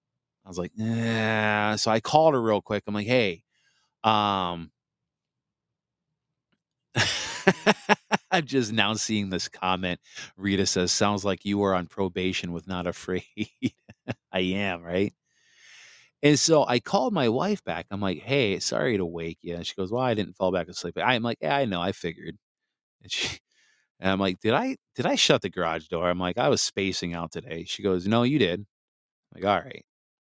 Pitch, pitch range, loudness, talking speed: 100 Hz, 90-115 Hz, -26 LUFS, 185 wpm